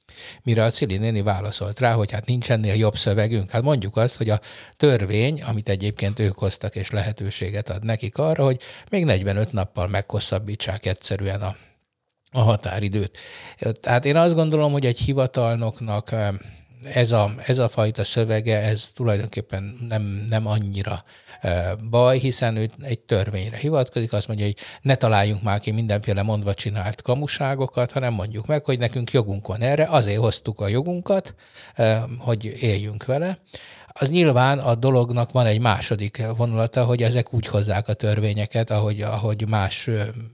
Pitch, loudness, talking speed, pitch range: 110 Hz, -22 LUFS, 155 wpm, 105-125 Hz